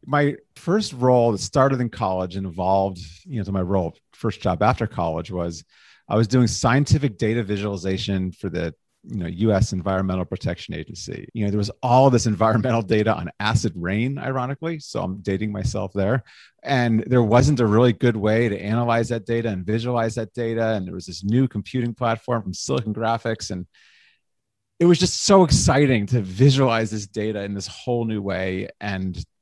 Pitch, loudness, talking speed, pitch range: 110 Hz, -22 LUFS, 185 wpm, 95-120 Hz